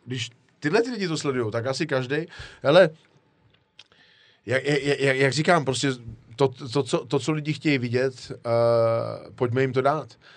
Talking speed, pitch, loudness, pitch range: 160 wpm, 135 Hz, -24 LUFS, 125-150 Hz